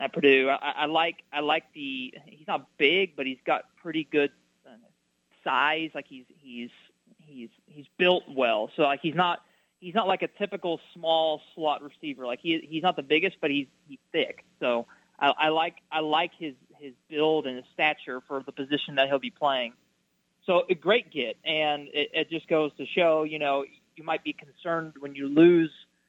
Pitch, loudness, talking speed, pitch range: 155 Hz, -27 LUFS, 200 wpm, 140-170 Hz